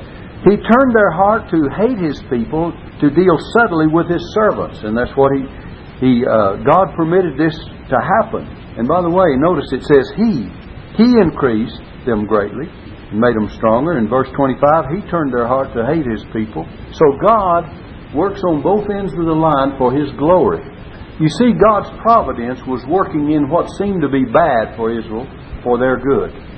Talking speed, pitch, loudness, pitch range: 185 wpm, 145 Hz, -15 LUFS, 120-185 Hz